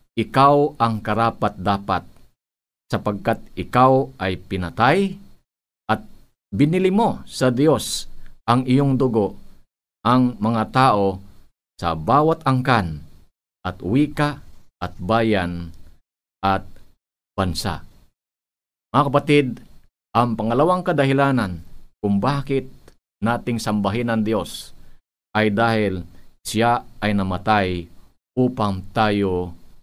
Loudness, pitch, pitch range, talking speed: -20 LUFS, 110 Hz, 95-130 Hz, 90 wpm